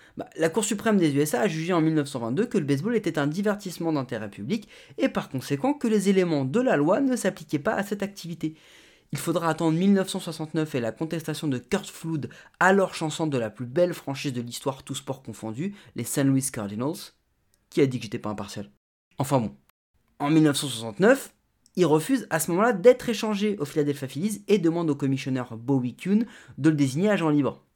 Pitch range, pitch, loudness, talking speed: 135-195 Hz, 155 Hz, -25 LUFS, 195 wpm